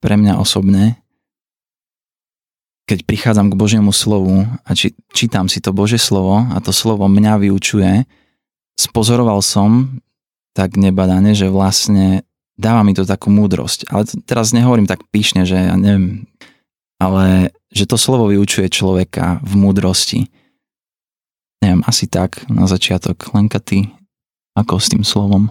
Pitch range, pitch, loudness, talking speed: 95-110 Hz, 100 Hz, -13 LUFS, 135 wpm